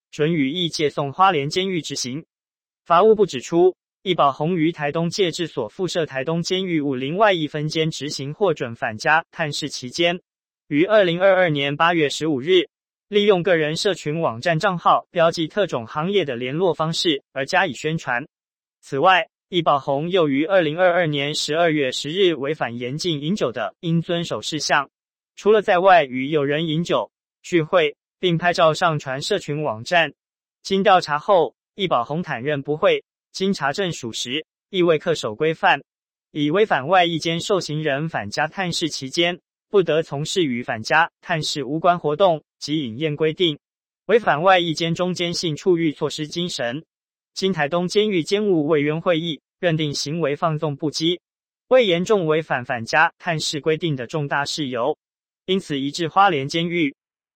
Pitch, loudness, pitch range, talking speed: 165 Hz, -20 LUFS, 150-180 Hz, 255 characters per minute